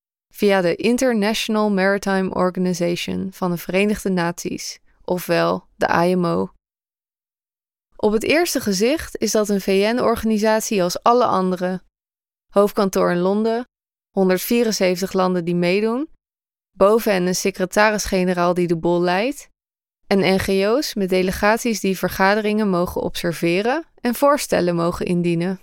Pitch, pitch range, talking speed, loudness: 195 Hz, 180-215 Hz, 115 wpm, -19 LUFS